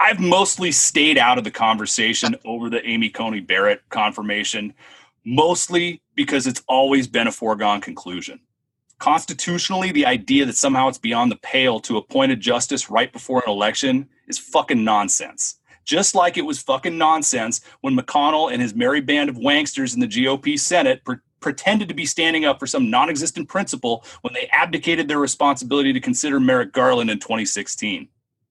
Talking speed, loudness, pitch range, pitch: 170 wpm, -19 LUFS, 130-200 Hz, 150 Hz